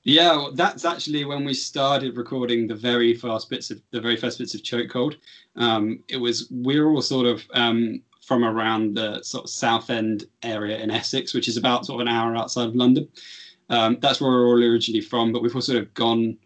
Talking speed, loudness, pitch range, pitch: 225 wpm, -22 LUFS, 115-125 Hz, 120 Hz